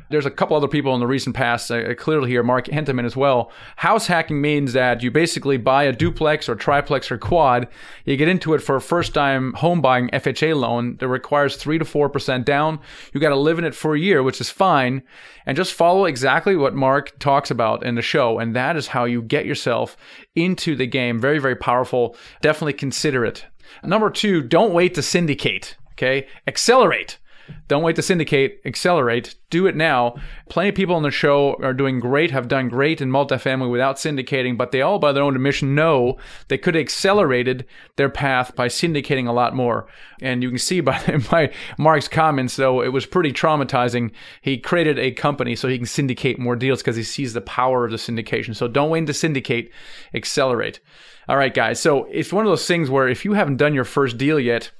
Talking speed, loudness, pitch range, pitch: 210 wpm, -19 LUFS, 125-155 Hz, 140 Hz